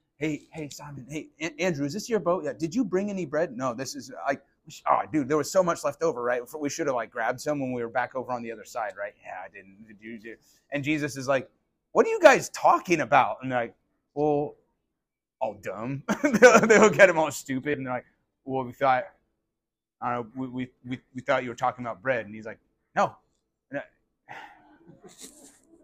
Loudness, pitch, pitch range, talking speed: -26 LUFS, 145 Hz, 125-165 Hz, 215 wpm